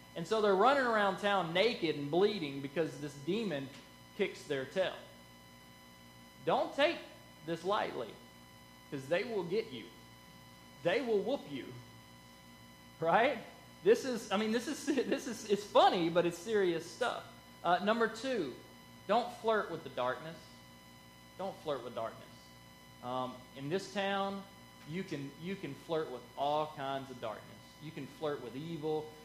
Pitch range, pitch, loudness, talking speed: 135-205 Hz, 165 Hz, -35 LUFS, 150 wpm